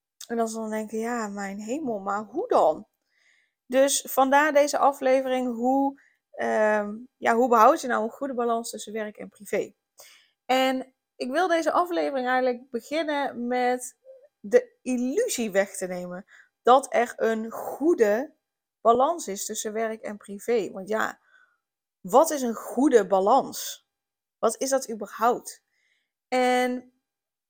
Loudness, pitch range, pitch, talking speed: -25 LUFS, 220-275 Hz, 250 Hz, 140 wpm